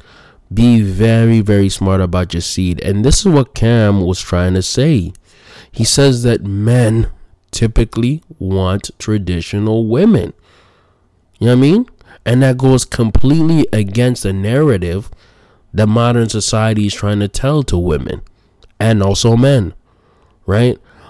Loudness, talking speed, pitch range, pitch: -13 LUFS, 140 wpm, 95-120 Hz, 110 Hz